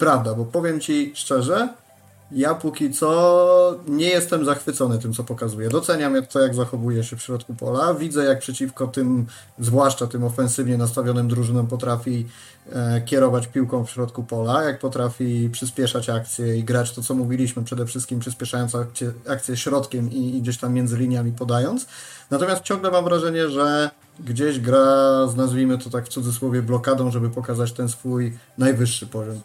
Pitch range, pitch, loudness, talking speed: 120-140 Hz, 125 Hz, -21 LUFS, 155 wpm